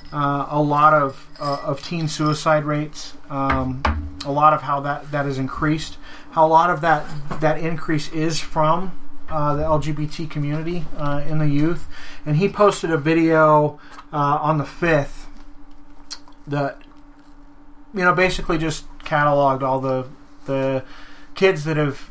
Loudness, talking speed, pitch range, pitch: -20 LUFS, 150 wpm, 145-165 Hz, 155 Hz